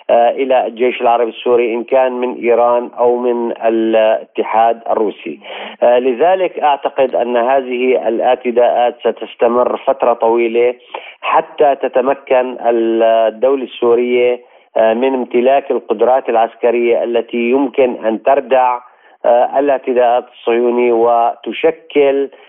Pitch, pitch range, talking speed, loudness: 120 Hz, 115-130 Hz, 95 wpm, -13 LUFS